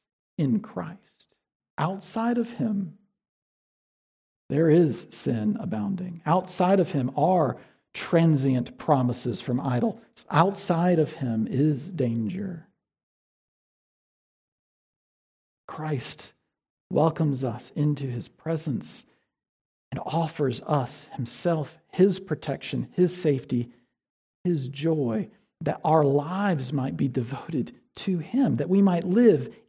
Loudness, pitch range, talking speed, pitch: -26 LUFS, 135-185 Hz, 100 wpm, 155 Hz